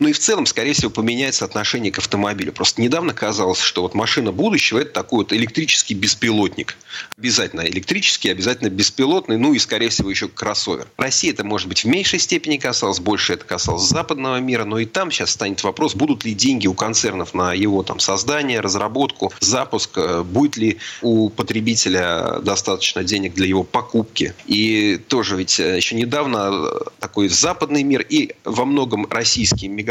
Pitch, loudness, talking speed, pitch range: 115 Hz, -18 LUFS, 170 wpm, 100-130 Hz